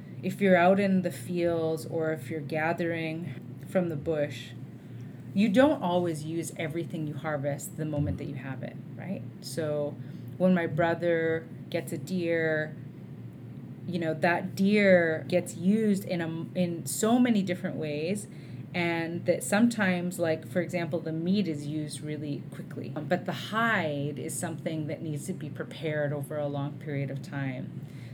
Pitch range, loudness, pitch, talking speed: 145-175 Hz, -29 LUFS, 160 Hz, 160 wpm